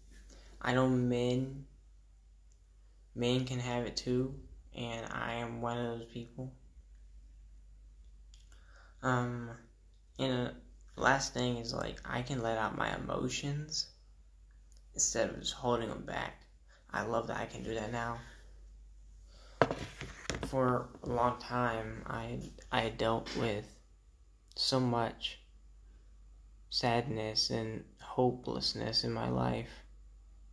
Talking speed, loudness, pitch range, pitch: 120 wpm, -35 LUFS, 80-125 Hz, 115 Hz